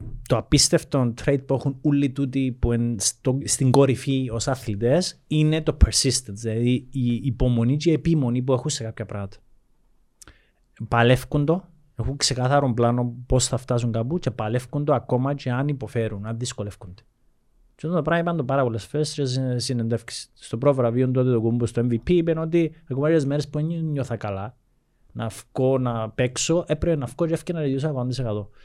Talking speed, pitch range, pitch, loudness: 160 wpm, 120-145 Hz, 130 Hz, -23 LUFS